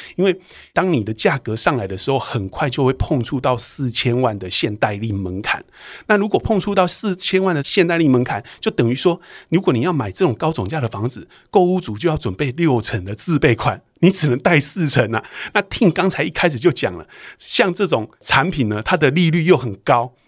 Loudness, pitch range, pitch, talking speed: -18 LUFS, 115-170 Hz, 135 Hz, 305 characters per minute